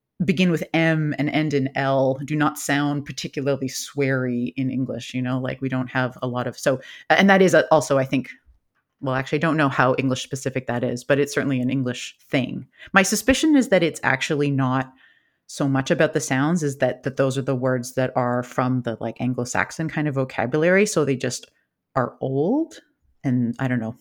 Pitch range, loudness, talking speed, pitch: 130-155 Hz, -22 LUFS, 205 wpm, 135 Hz